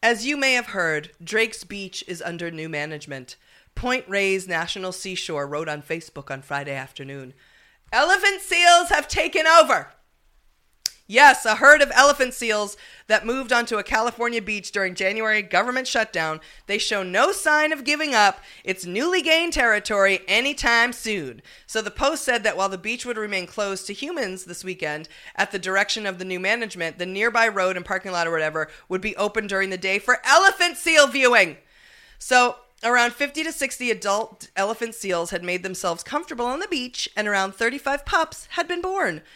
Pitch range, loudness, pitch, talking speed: 185-250 Hz, -21 LUFS, 210 Hz, 180 wpm